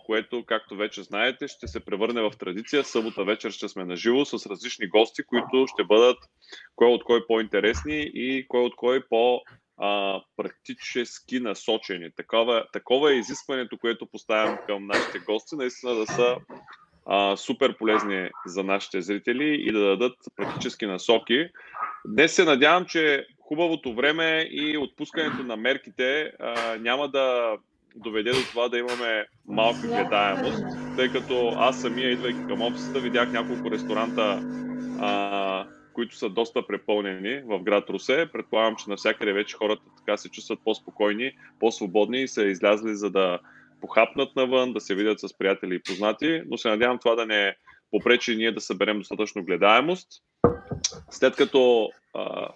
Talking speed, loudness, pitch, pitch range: 150 wpm, -25 LUFS, 115 Hz, 105-130 Hz